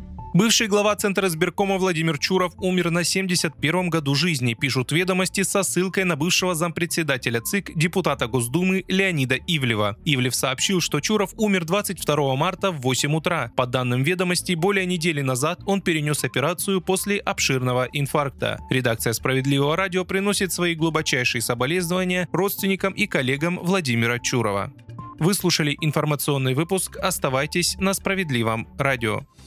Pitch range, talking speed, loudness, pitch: 135-190 Hz, 130 wpm, -22 LUFS, 170 Hz